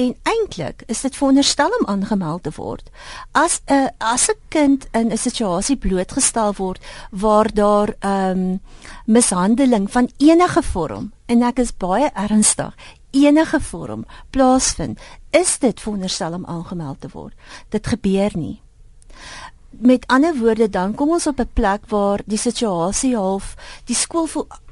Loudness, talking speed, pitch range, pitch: -18 LUFS, 150 wpm, 195-275 Hz, 230 Hz